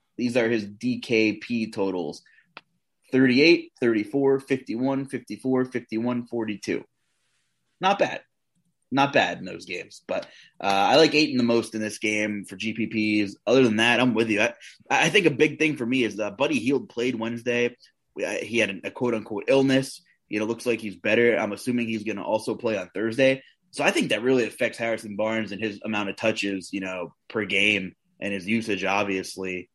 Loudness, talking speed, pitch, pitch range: -24 LUFS, 190 wpm, 115 Hz, 105-125 Hz